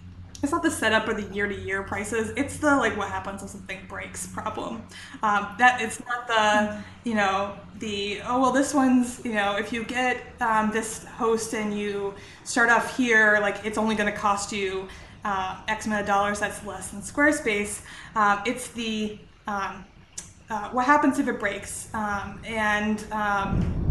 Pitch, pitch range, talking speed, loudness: 215 Hz, 200-235 Hz, 185 wpm, -25 LUFS